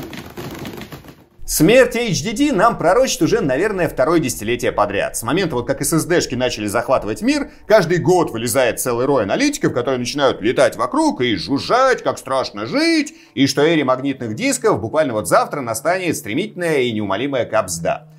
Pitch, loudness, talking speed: 170 Hz, -17 LUFS, 150 wpm